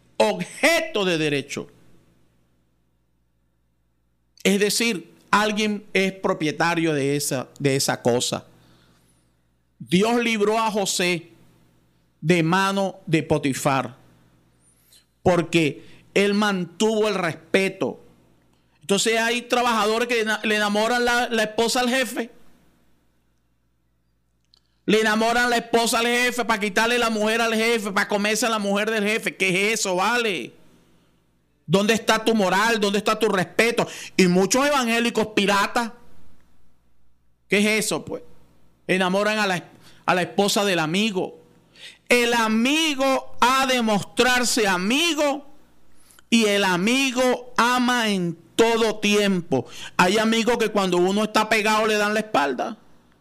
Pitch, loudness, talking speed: 200 Hz, -21 LUFS, 125 wpm